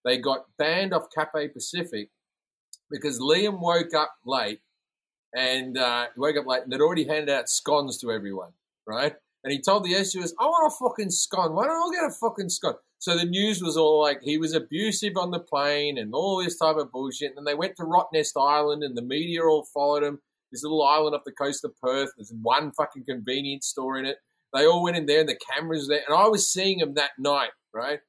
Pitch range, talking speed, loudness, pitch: 140-175 Hz, 225 wpm, -25 LUFS, 150 Hz